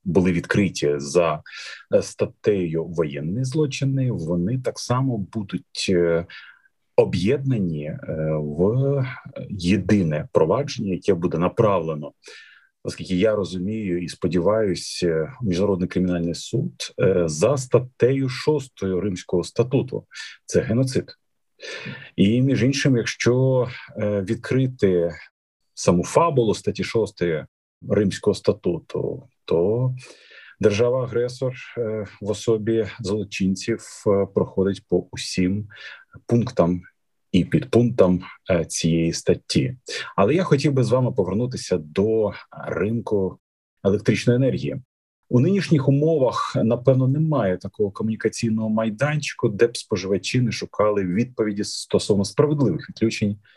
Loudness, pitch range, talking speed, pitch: -22 LUFS, 90-125 Hz, 95 wpm, 110 Hz